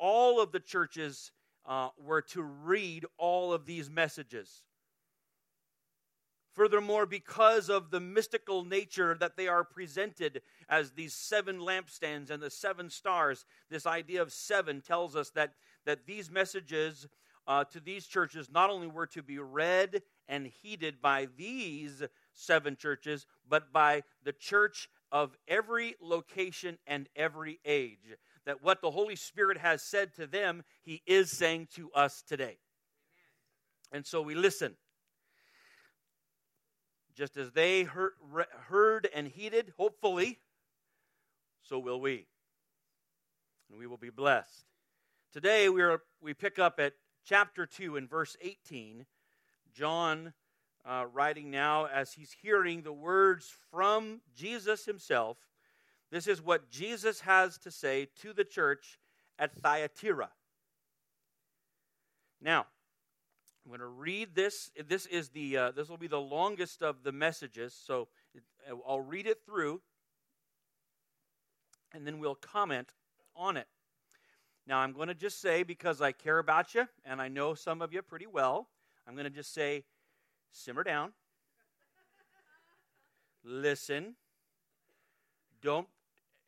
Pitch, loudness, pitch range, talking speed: 165 Hz, -33 LUFS, 145-195 Hz, 135 wpm